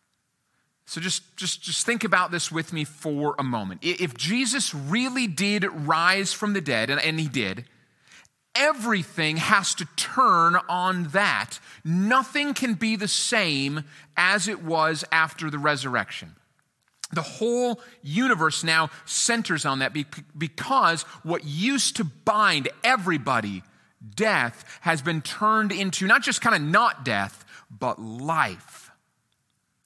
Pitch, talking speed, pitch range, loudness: 170 Hz, 135 wpm, 150-215 Hz, -23 LUFS